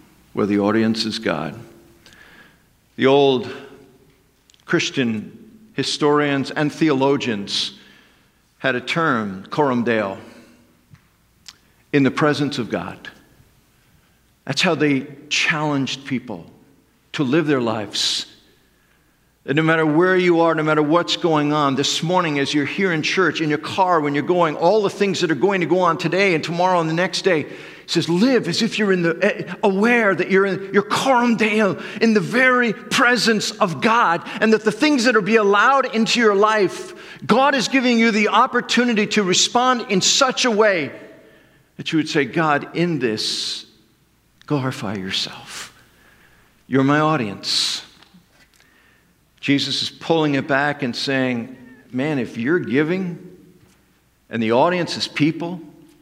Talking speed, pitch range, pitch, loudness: 150 wpm, 140-205 Hz, 165 Hz, -18 LUFS